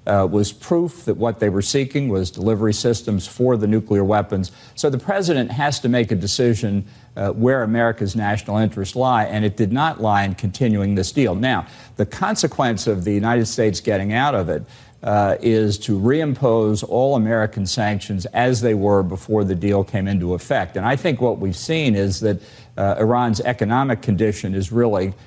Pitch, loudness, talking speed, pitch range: 110 Hz, -19 LUFS, 190 wpm, 100-125 Hz